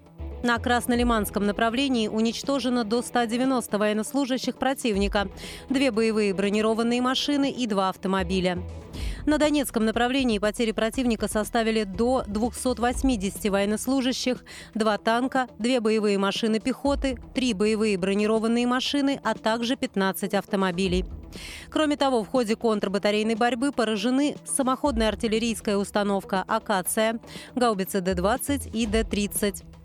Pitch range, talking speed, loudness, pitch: 210-255 Hz, 105 wpm, -25 LUFS, 225 Hz